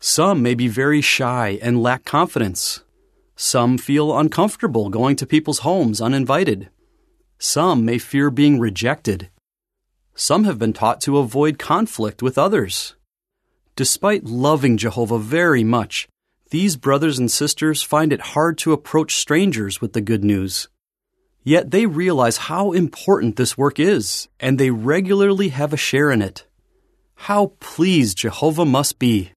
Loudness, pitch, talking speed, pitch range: -18 LUFS, 145 Hz, 145 wpm, 120-170 Hz